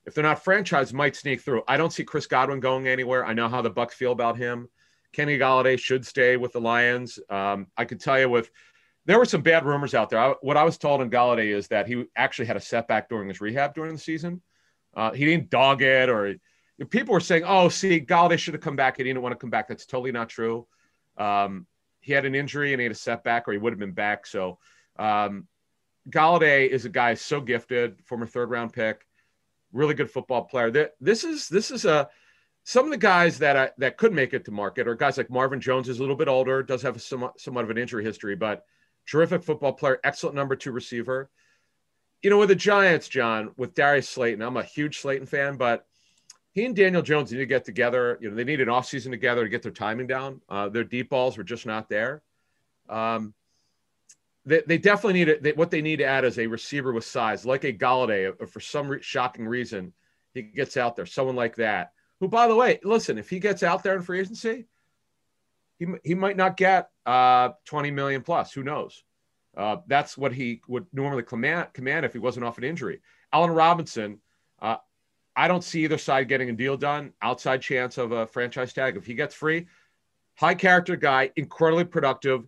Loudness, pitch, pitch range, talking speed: -24 LUFS, 130 Hz, 120-155 Hz, 220 wpm